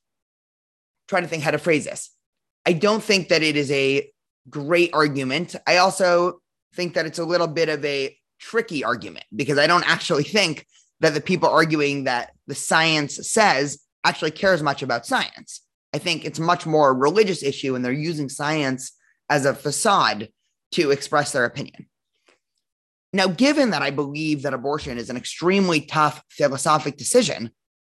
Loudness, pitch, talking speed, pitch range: -21 LUFS, 150 Hz, 170 wpm, 140-175 Hz